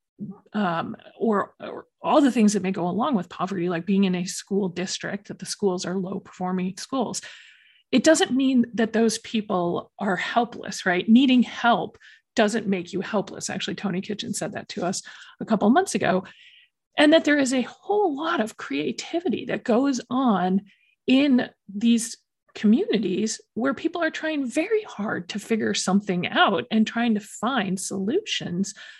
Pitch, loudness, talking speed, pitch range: 220 Hz, -24 LUFS, 170 wpm, 195-255 Hz